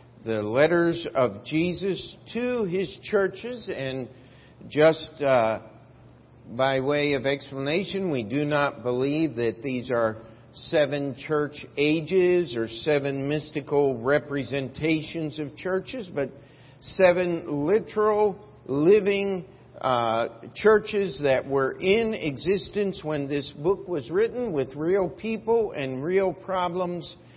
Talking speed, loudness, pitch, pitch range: 110 wpm, -25 LUFS, 150 Hz, 135-185 Hz